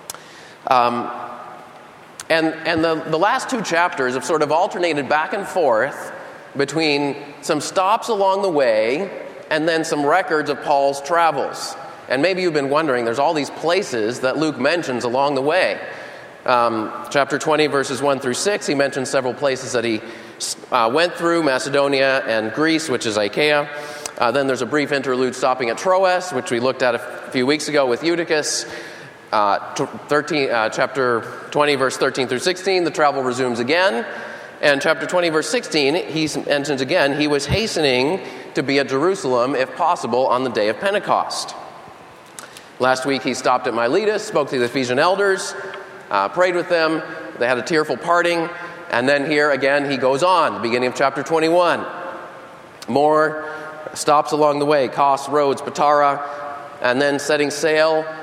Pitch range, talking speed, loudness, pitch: 130-160 Hz, 170 wpm, -19 LUFS, 145 Hz